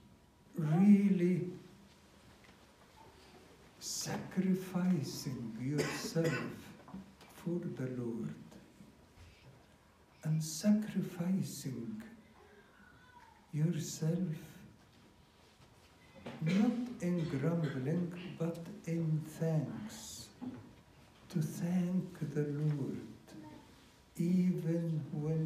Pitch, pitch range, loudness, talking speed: 165 Hz, 135-180 Hz, -36 LUFS, 50 wpm